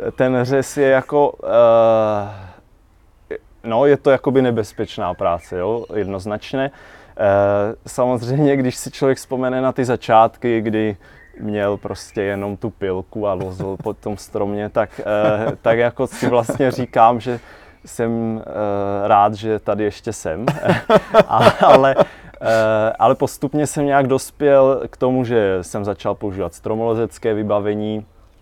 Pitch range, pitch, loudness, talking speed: 105-130 Hz, 110 Hz, -18 LUFS, 135 wpm